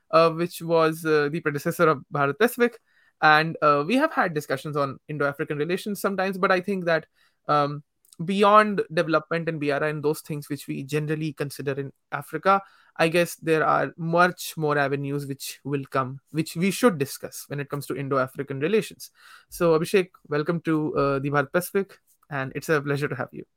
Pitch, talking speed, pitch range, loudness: 155 Hz, 185 wpm, 145-175 Hz, -24 LUFS